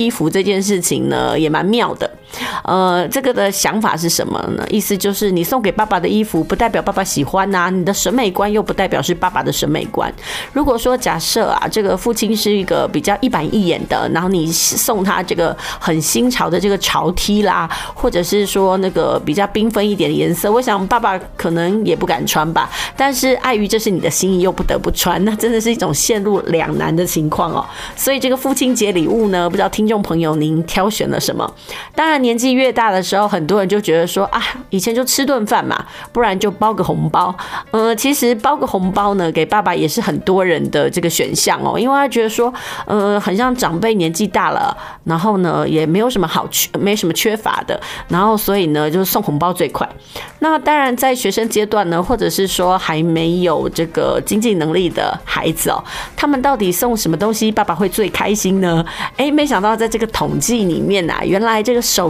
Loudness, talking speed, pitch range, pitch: -15 LUFS, 320 characters per minute, 180-230 Hz, 205 Hz